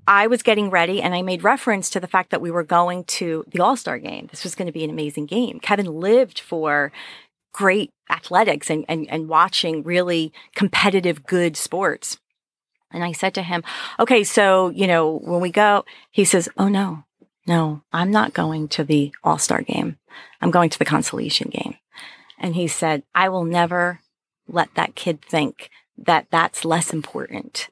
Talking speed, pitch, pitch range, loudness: 185 wpm, 175 Hz, 160-200 Hz, -20 LUFS